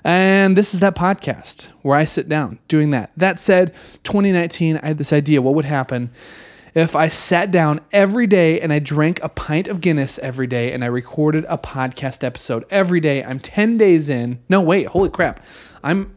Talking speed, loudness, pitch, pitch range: 195 wpm, -17 LUFS, 155 Hz, 135-185 Hz